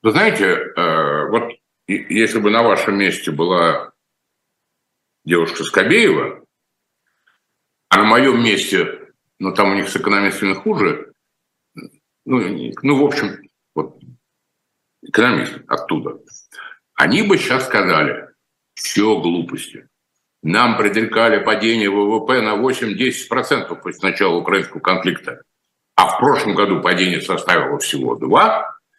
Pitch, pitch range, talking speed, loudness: 110 Hz, 100-145 Hz, 110 wpm, -16 LUFS